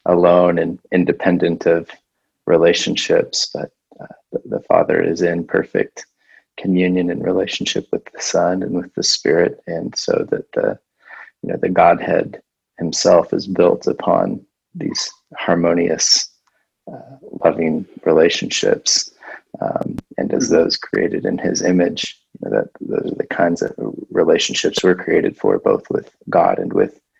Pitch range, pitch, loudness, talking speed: 85-100 Hz, 90 Hz, -17 LUFS, 145 wpm